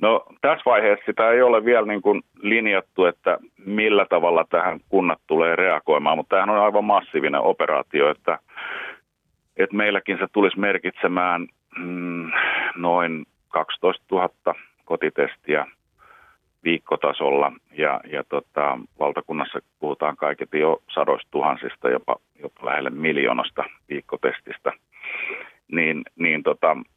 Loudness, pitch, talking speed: -22 LUFS, 105 Hz, 115 wpm